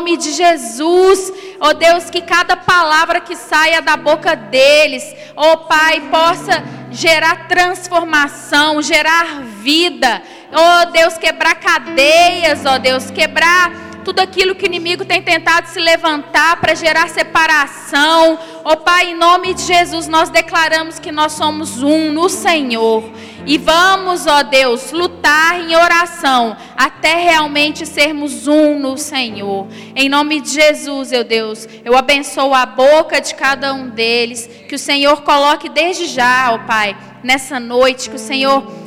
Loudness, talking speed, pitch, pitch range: -12 LUFS, 155 wpm, 310 Hz, 275-335 Hz